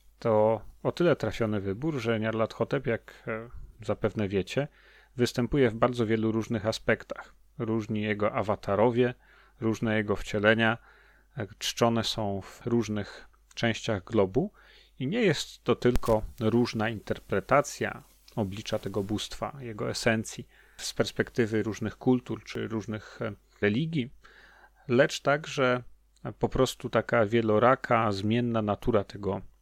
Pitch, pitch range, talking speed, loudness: 110 Hz, 105-120 Hz, 115 wpm, -29 LUFS